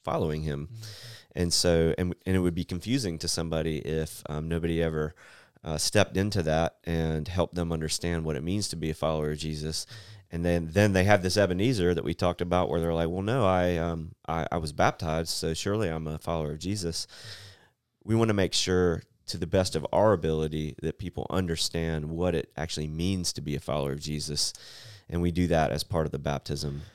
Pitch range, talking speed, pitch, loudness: 80-95 Hz, 210 wpm, 85 Hz, -28 LUFS